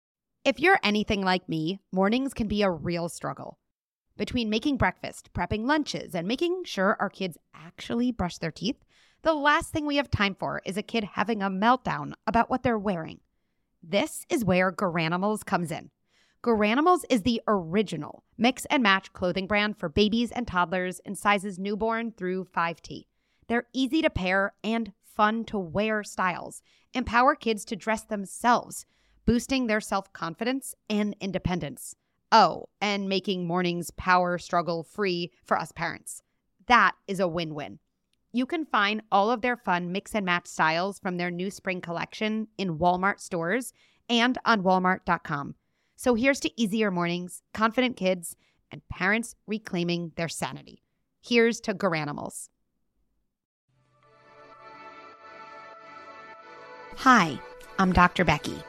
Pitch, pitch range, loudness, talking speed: 205 Hz, 180-230 Hz, -26 LUFS, 145 wpm